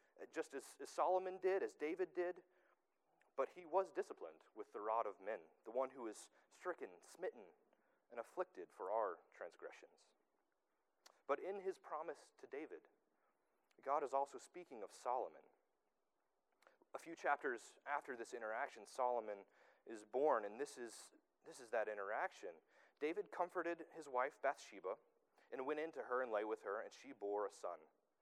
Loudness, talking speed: -46 LUFS, 155 wpm